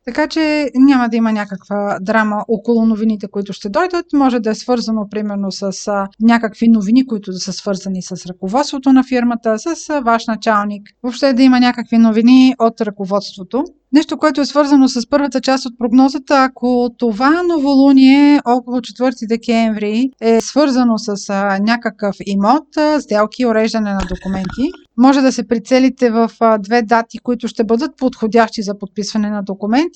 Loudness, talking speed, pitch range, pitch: -14 LUFS, 155 wpm, 210-265 Hz, 235 Hz